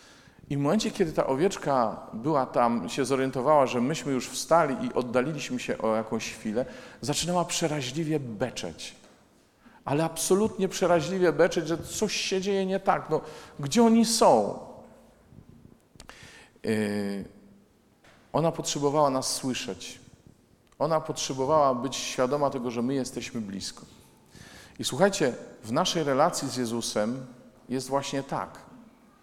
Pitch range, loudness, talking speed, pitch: 125-175 Hz, -27 LUFS, 125 wpm, 145 Hz